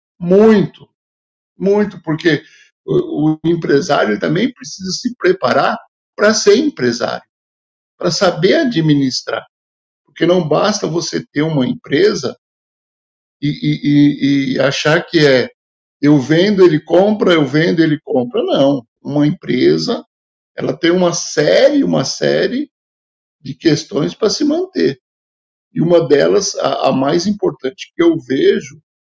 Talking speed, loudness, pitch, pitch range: 130 wpm, -14 LUFS, 155 Hz, 135-185 Hz